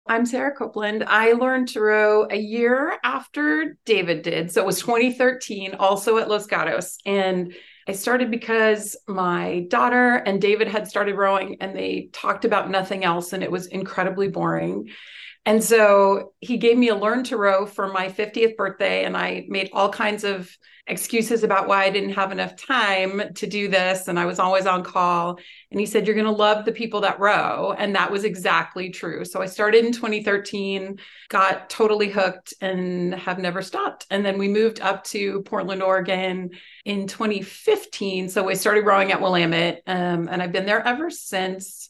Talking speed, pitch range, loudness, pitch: 185 wpm, 190-220 Hz, -21 LUFS, 200 Hz